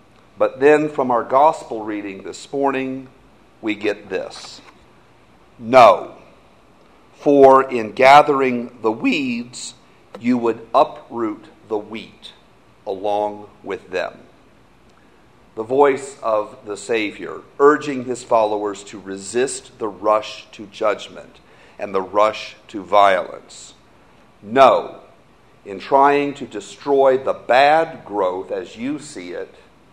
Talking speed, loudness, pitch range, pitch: 110 wpm, -18 LUFS, 105-140 Hz, 125 Hz